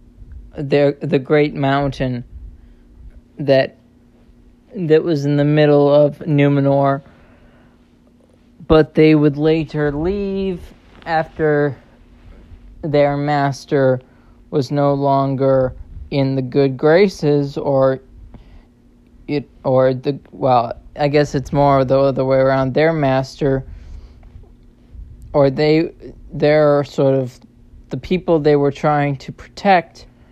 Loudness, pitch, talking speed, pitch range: -16 LUFS, 145 Hz, 105 wpm, 130-150 Hz